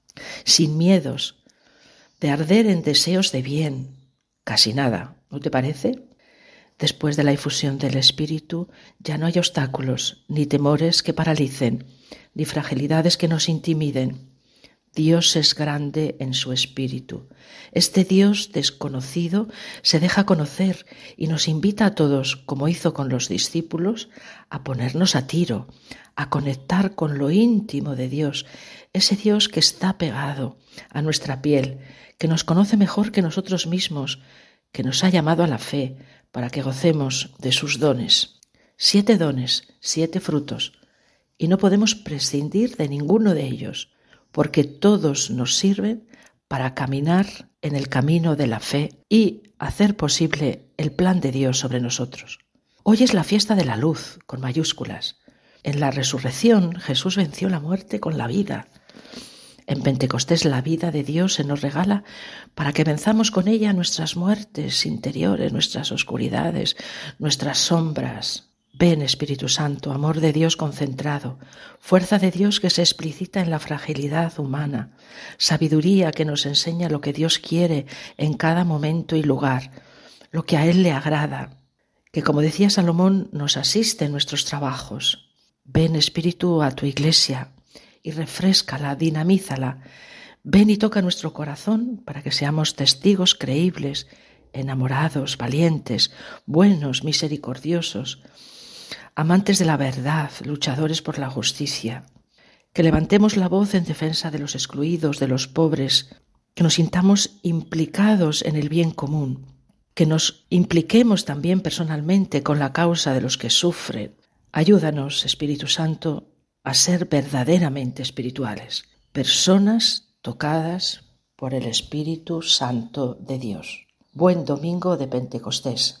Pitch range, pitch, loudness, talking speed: 140-180 Hz, 155 Hz, -21 LUFS, 140 wpm